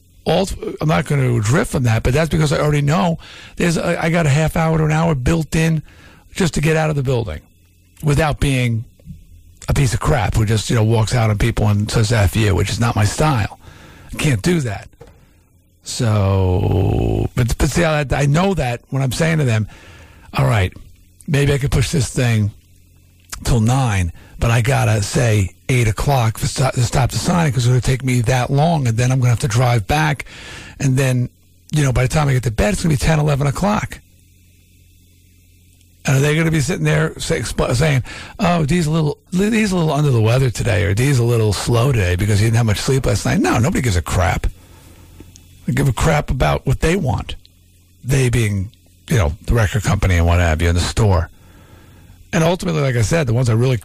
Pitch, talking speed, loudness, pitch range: 120 Hz, 230 wpm, -17 LUFS, 95-145 Hz